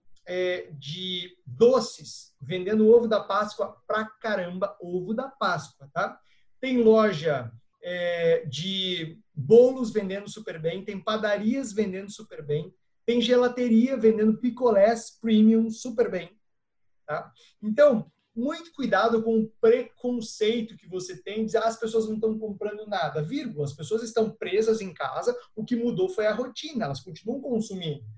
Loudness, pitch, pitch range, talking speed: -26 LUFS, 215 Hz, 180-230 Hz, 145 wpm